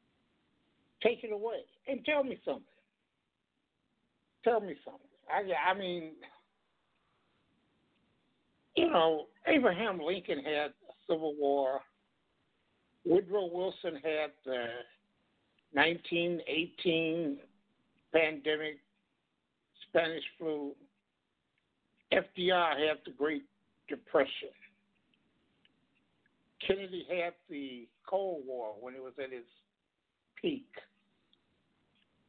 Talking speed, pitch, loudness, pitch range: 85 wpm, 170 Hz, -34 LUFS, 150-195 Hz